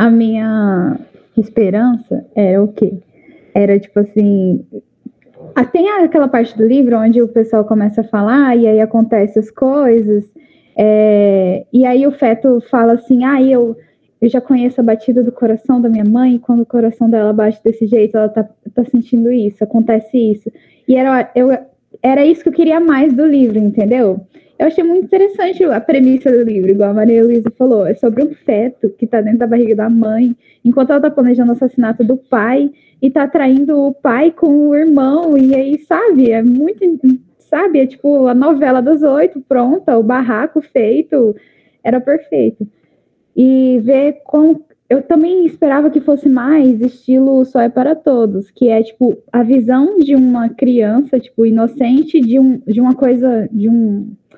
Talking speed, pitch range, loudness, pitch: 175 wpm, 225-280 Hz, -12 LUFS, 250 Hz